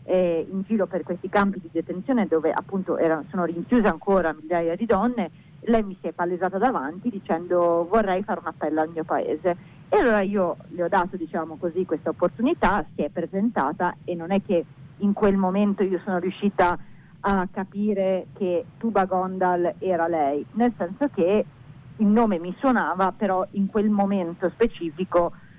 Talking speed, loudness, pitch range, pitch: 170 wpm, -24 LUFS, 170-200 Hz, 180 Hz